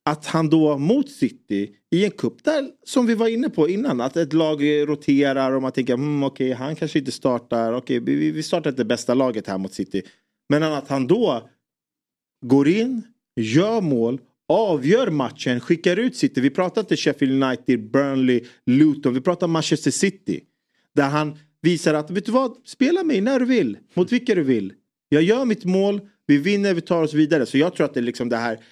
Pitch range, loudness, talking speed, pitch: 130-195 Hz, -21 LUFS, 205 wpm, 150 Hz